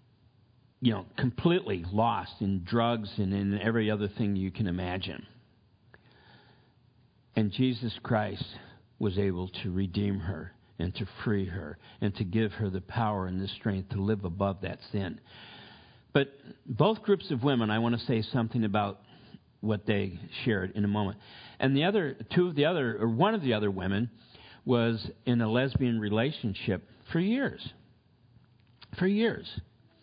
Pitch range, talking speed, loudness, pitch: 100-125 Hz, 160 wpm, -30 LUFS, 110 Hz